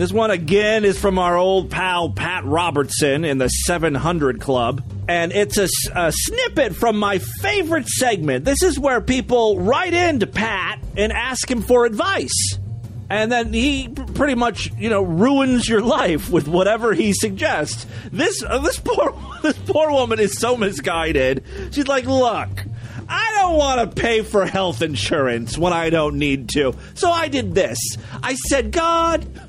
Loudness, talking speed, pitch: -19 LUFS, 170 wpm, 200 Hz